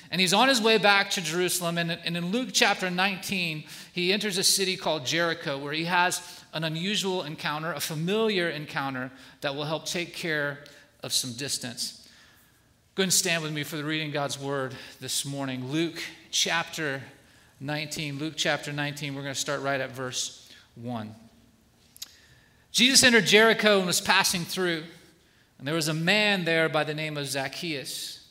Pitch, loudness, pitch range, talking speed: 160 Hz, -25 LUFS, 140-180 Hz, 175 wpm